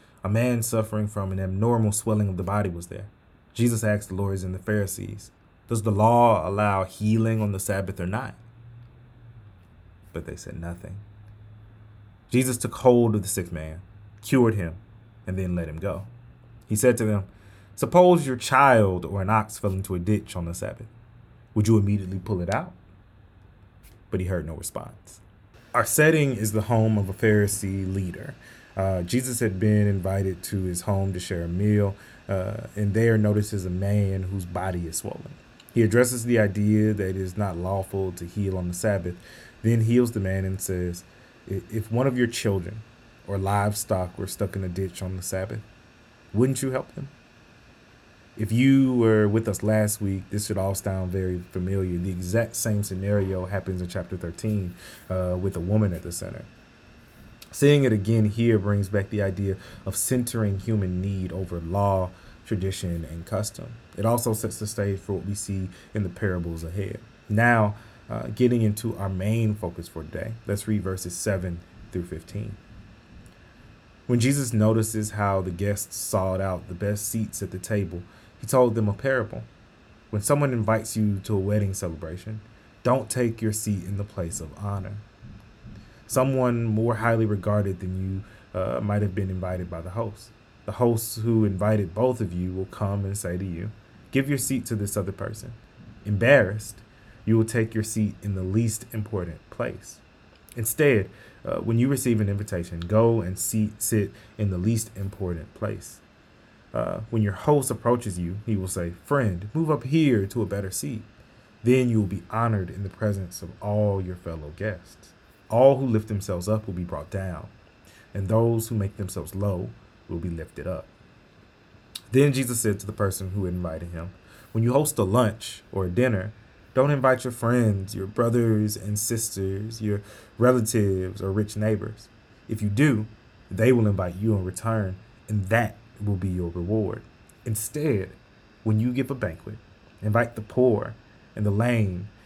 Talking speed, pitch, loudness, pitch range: 180 wpm, 105 Hz, -25 LUFS, 95-115 Hz